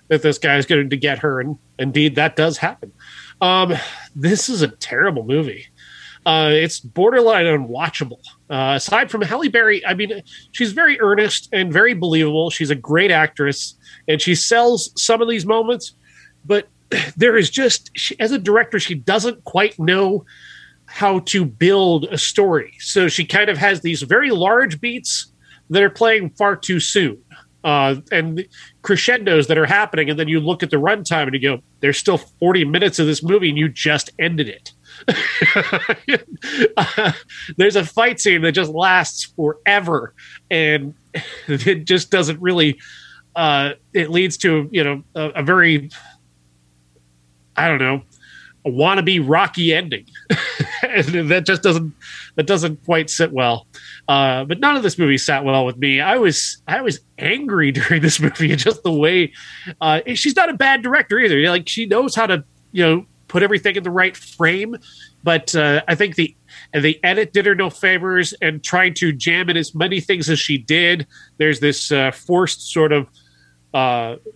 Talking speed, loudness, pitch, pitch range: 175 wpm, -16 LUFS, 165 Hz, 150-195 Hz